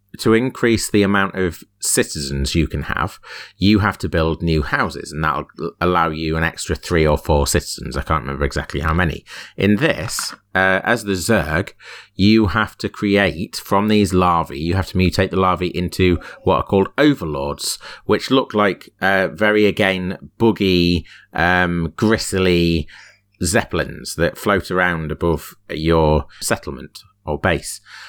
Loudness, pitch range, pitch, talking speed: -18 LUFS, 80-100 Hz, 90 Hz, 155 wpm